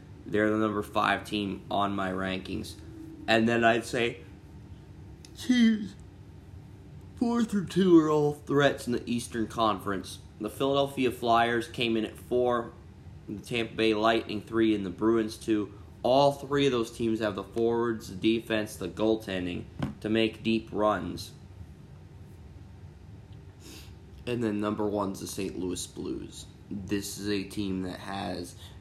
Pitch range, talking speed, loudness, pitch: 95-115 Hz, 145 wpm, -28 LUFS, 105 Hz